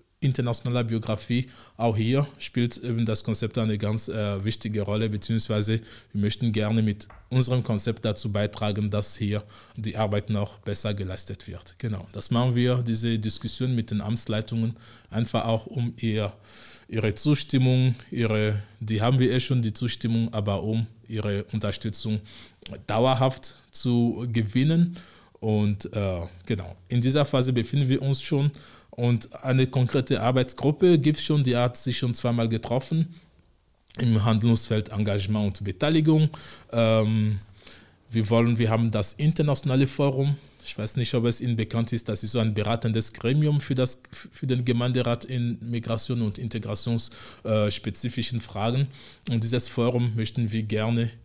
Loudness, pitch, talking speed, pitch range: -26 LUFS, 115 Hz, 150 wpm, 110-125 Hz